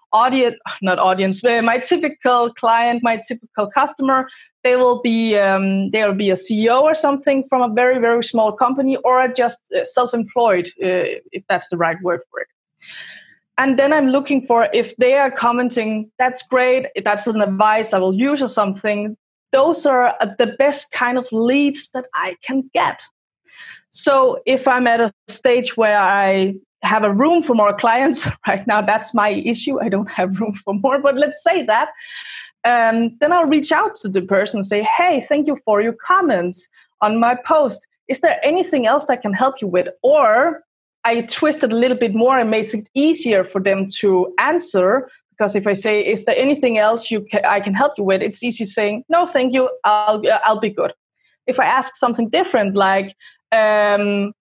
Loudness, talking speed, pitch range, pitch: -17 LUFS, 195 wpm, 210-270 Hz, 235 Hz